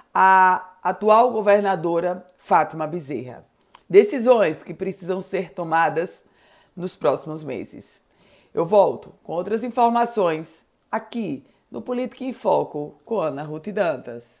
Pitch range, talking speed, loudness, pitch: 165-215 Hz, 110 wpm, -21 LUFS, 185 Hz